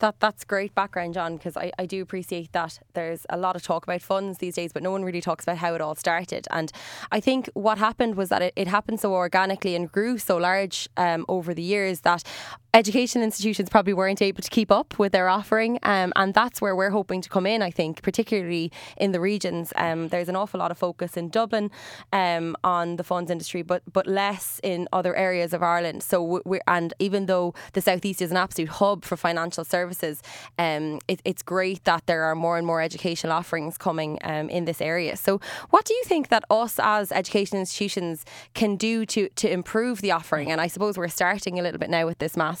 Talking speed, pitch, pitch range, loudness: 225 wpm, 185 Hz, 170-200 Hz, -25 LUFS